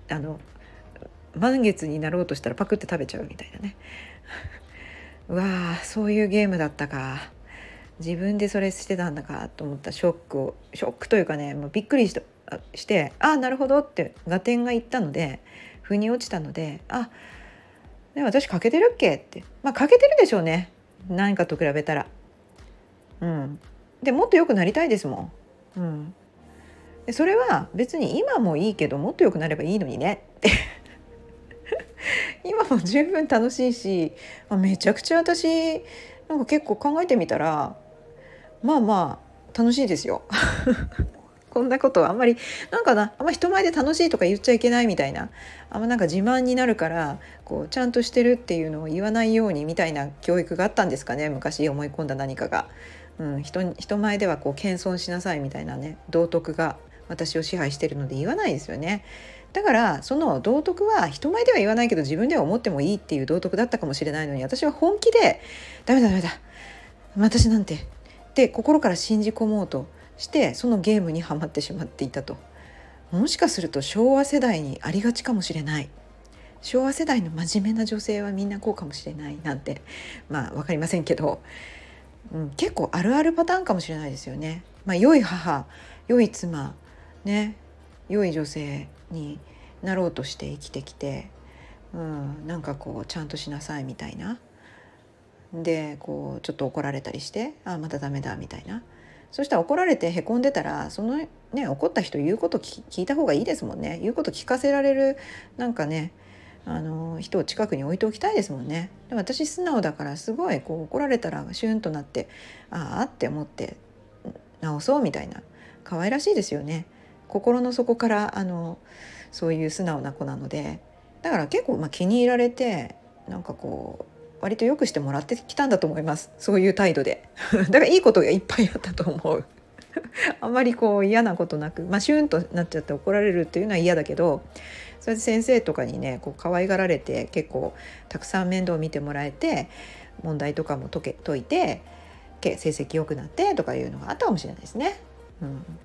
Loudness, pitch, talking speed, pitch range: -24 LUFS, 180 Hz, 370 characters per minute, 150-235 Hz